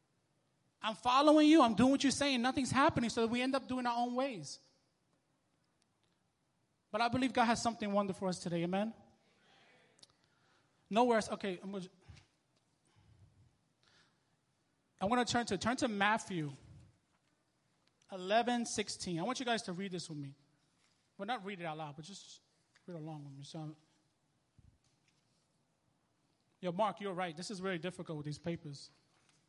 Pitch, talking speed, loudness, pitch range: 185 Hz, 160 wpm, -34 LUFS, 155-230 Hz